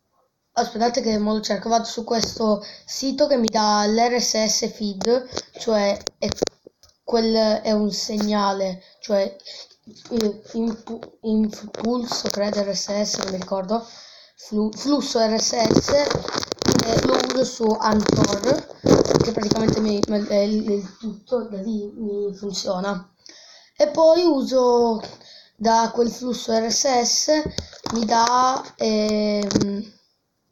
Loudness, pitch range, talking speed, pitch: -21 LUFS, 210-235 Hz, 115 wpm, 220 Hz